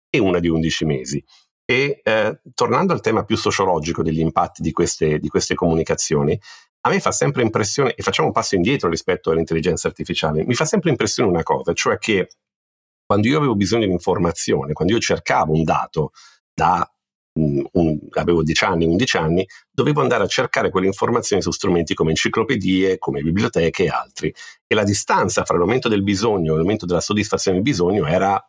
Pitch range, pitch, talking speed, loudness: 80-100 Hz, 85 Hz, 185 wpm, -19 LUFS